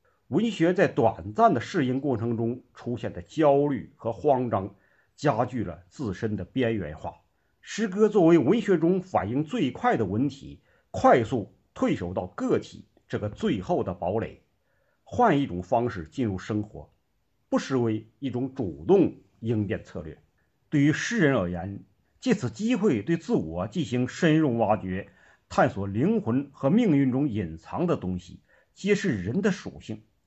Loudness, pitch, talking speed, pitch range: -26 LUFS, 120 Hz, 225 characters per minute, 105-150 Hz